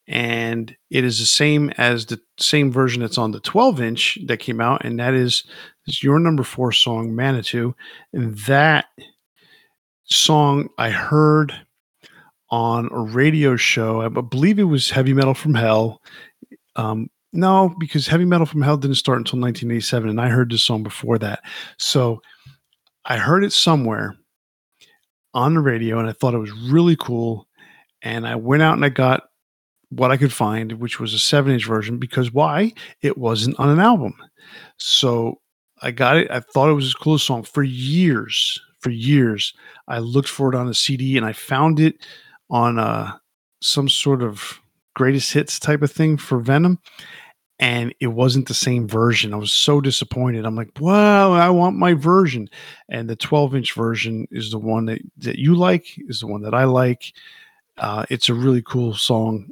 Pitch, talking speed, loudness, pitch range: 130 Hz, 180 wpm, -18 LUFS, 115-150 Hz